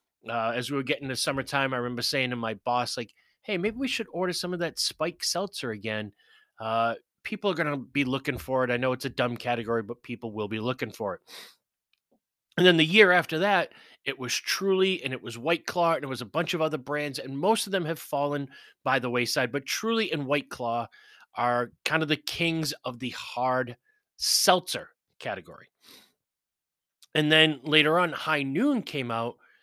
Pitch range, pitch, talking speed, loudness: 125-165 Hz, 140 Hz, 205 wpm, -27 LUFS